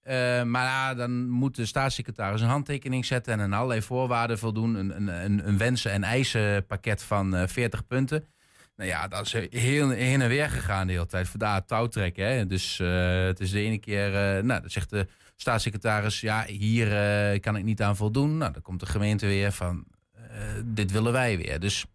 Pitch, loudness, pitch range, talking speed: 110 Hz, -27 LUFS, 100-125 Hz, 195 wpm